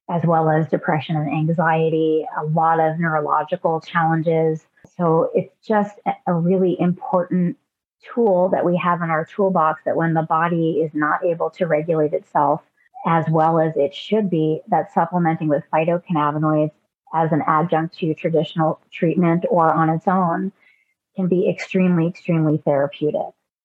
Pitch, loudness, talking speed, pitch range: 165 Hz, -20 LUFS, 150 wpm, 155-180 Hz